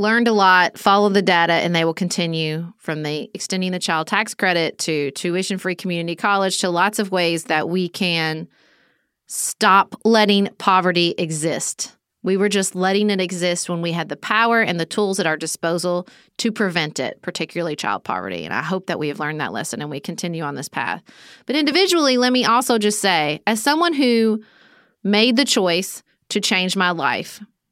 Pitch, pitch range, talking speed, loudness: 185 Hz, 170-210 Hz, 190 wpm, -19 LUFS